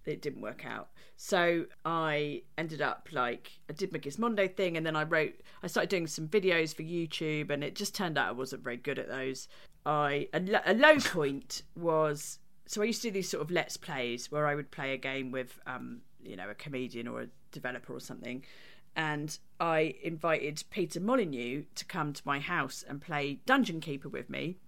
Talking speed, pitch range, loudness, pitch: 205 wpm, 140-170 Hz, -33 LUFS, 155 Hz